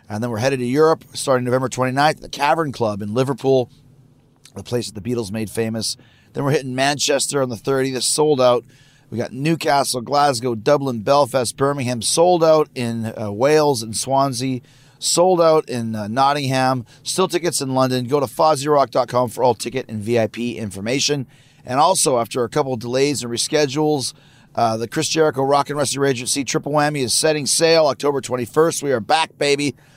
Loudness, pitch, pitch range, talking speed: -19 LUFS, 135 Hz, 120-145 Hz, 180 wpm